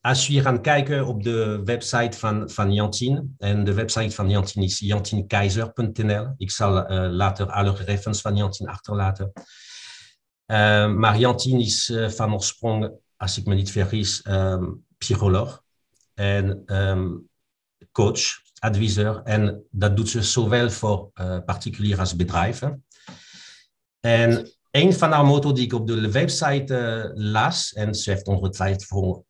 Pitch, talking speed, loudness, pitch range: 105 Hz, 145 wpm, -22 LUFS, 100-120 Hz